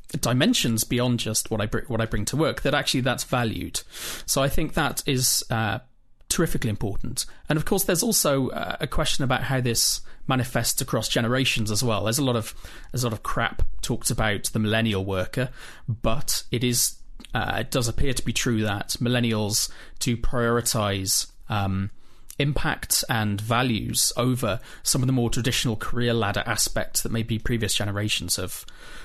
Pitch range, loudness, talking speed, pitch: 110-130 Hz, -24 LUFS, 175 wpm, 120 Hz